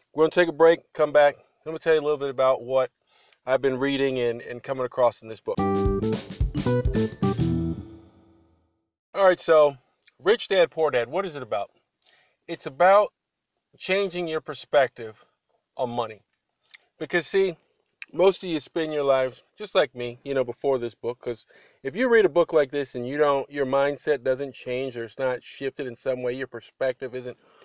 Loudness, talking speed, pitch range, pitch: -24 LUFS, 185 wpm, 120-155 Hz, 130 Hz